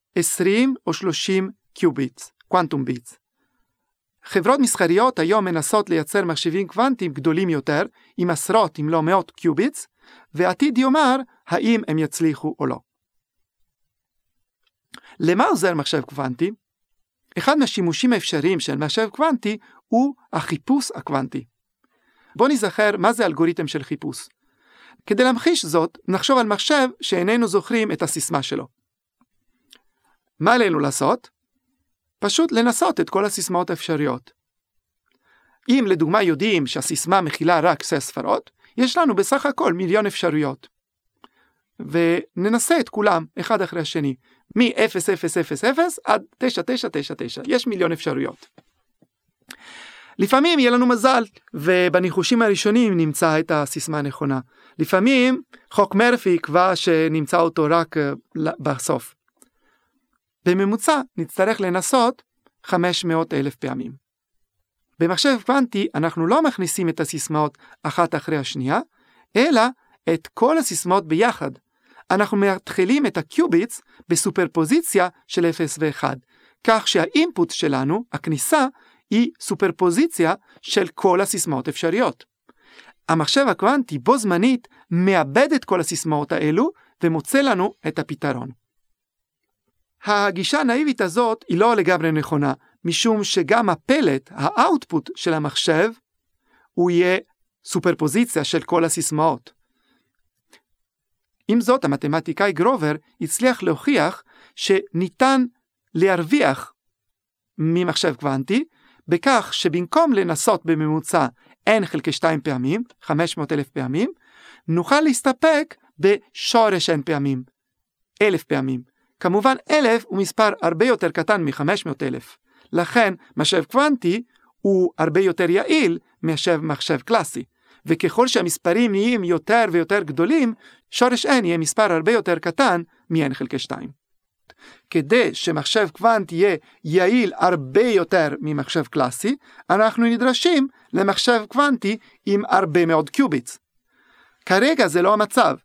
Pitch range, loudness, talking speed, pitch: 160-235 Hz, -20 LUFS, 110 wpm, 185 Hz